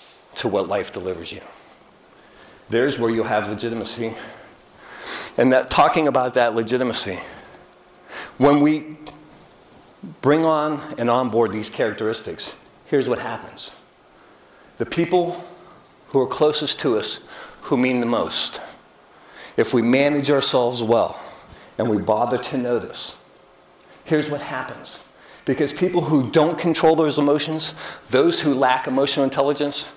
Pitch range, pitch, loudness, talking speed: 120-150 Hz, 140 Hz, -21 LUFS, 125 wpm